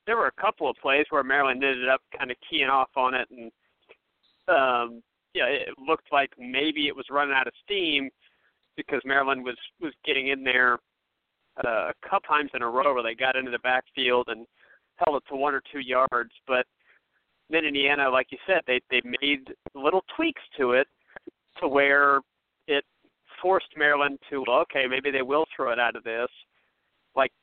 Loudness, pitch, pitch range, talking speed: -25 LUFS, 135 Hz, 125-145 Hz, 190 wpm